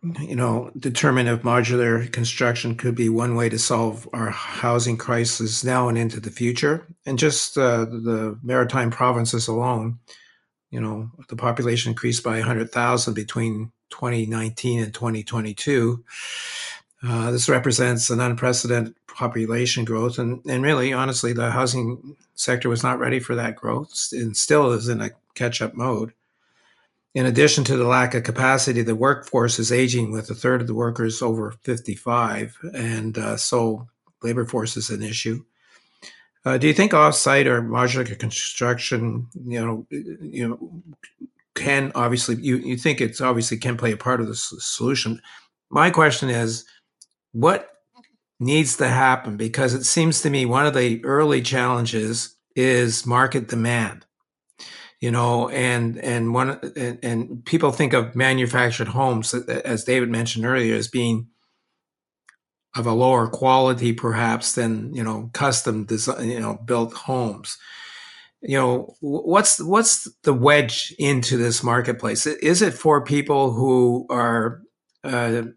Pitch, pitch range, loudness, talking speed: 120 Hz, 115-130 Hz, -21 LUFS, 150 wpm